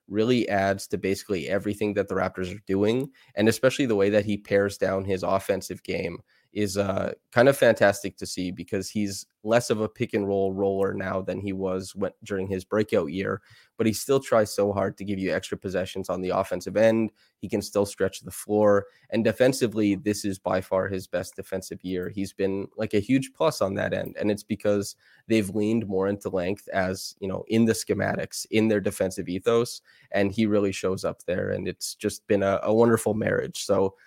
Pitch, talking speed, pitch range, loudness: 100 Hz, 210 wpm, 95-105 Hz, -26 LUFS